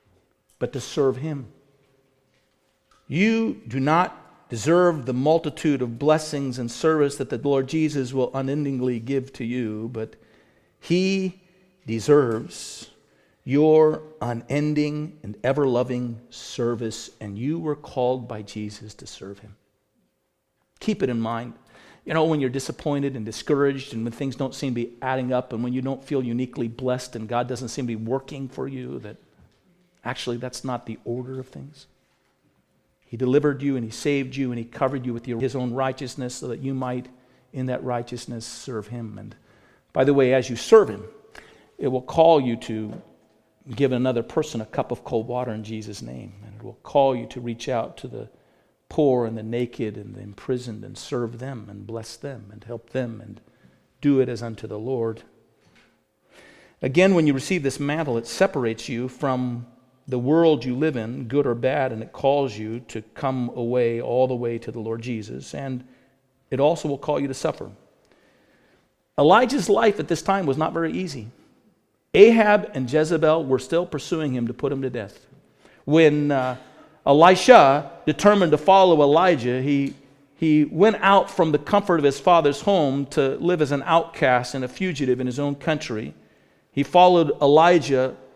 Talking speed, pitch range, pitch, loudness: 175 wpm, 120-150 Hz, 130 Hz, -22 LUFS